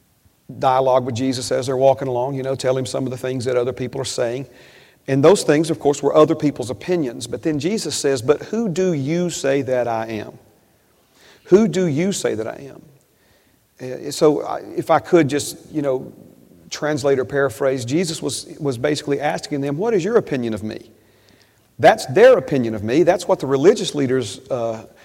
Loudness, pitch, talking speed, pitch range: -19 LUFS, 135 Hz, 200 wpm, 130-155 Hz